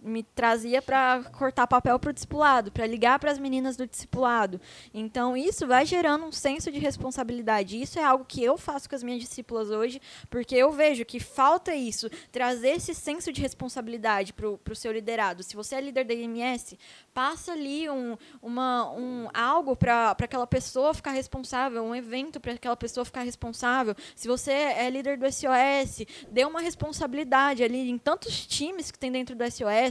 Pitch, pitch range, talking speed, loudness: 255 Hz, 235-280 Hz, 185 wpm, -27 LUFS